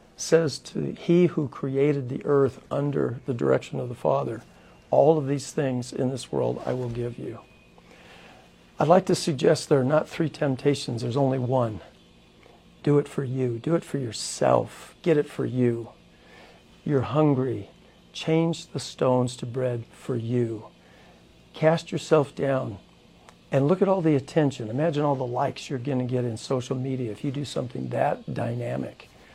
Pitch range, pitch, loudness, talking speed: 125-150 Hz, 135 Hz, -25 LUFS, 170 wpm